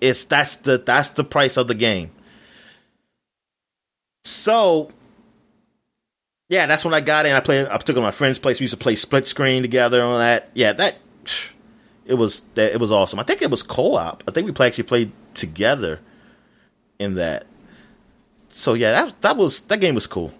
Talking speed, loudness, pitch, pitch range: 190 wpm, -19 LUFS, 130 Hz, 120-150 Hz